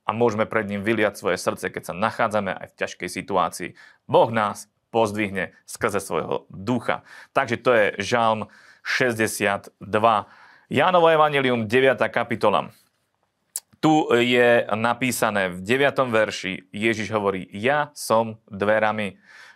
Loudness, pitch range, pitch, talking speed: -22 LUFS, 100-125 Hz, 110 Hz, 125 wpm